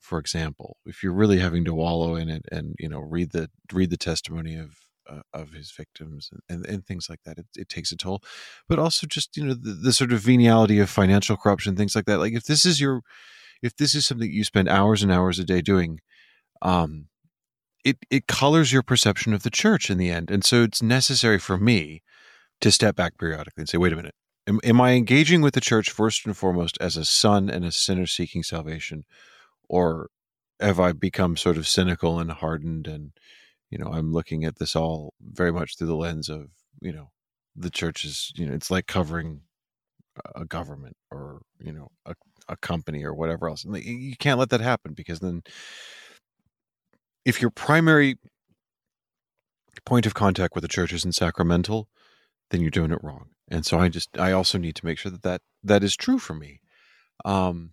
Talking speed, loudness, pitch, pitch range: 205 wpm, -23 LUFS, 90 Hz, 80-110 Hz